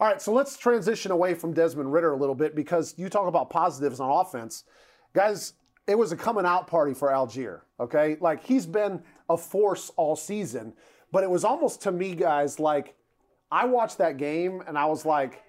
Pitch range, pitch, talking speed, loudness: 150-205 Hz, 170 Hz, 200 wpm, -26 LUFS